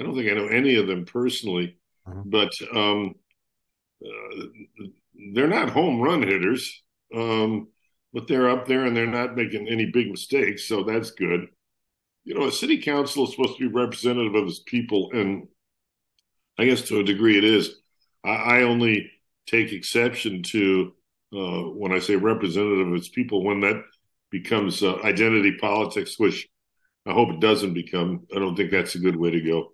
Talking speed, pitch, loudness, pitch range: 180 wpm, 110 Hz, -23 LUFS, 95-120 Hz